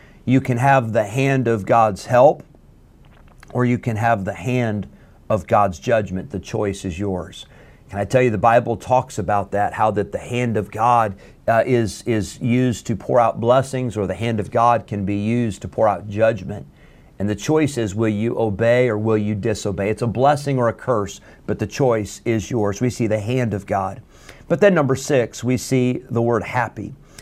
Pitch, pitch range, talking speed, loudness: 115 Hz, 100-125 Hz, 205 wpm, -20 LUFS